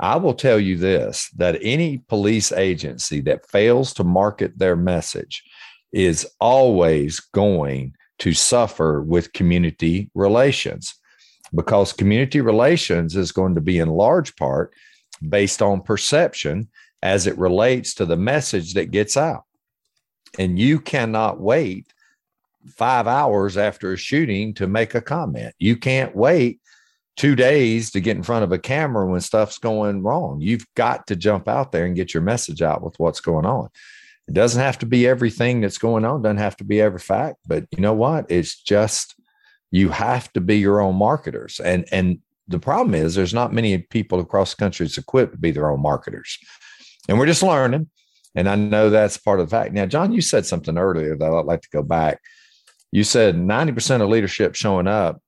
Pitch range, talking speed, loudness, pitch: 90-120 Hz, 180 wpm, -19 LUFS, 105 Hz